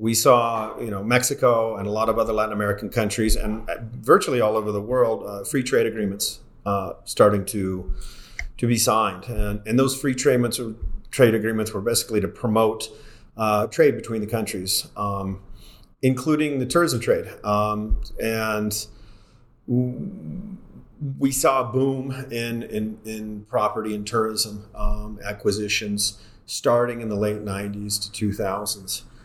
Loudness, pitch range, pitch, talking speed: -23 LUFS, 105-120 Hz, 110 Hz, 150 wpm